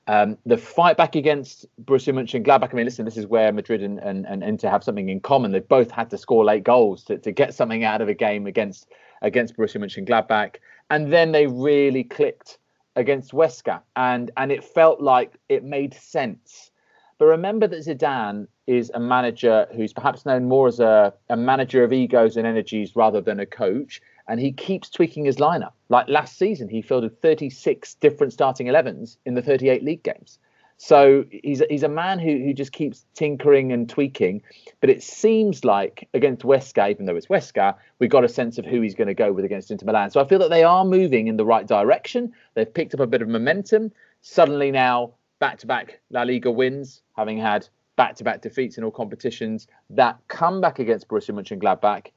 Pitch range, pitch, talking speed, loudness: 115-160 Hz, 135 Hz, 205 wpm, -20 LUFS